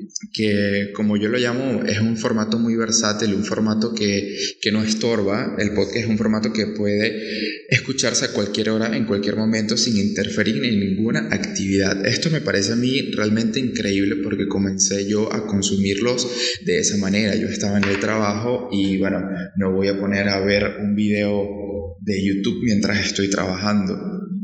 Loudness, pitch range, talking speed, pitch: -20 LUFS, 100-115 Hz, 170 wpm, 105 Hz